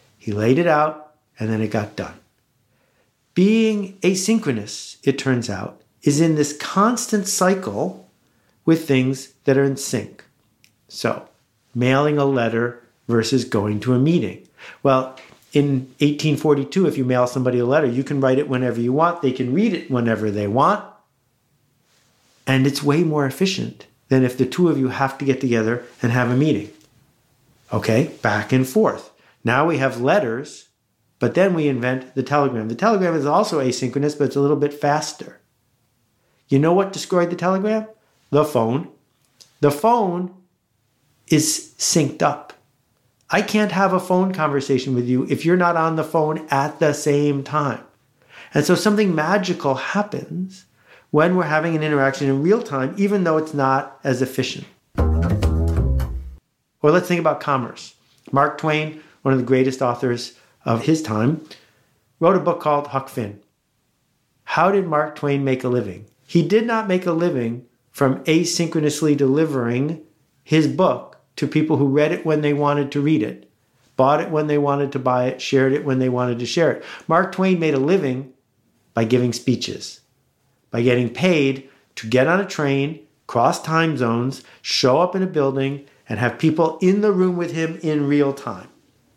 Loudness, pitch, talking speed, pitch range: -20 LUFS, 140 Hz, 170 wpm, 125-160 Hz